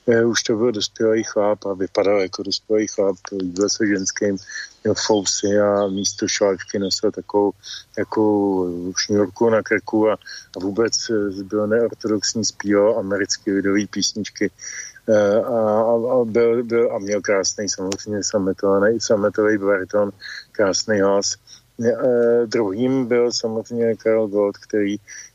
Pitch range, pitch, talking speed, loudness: 100-110 Hz, 105 Hz, 125 wpm, -20 LUFS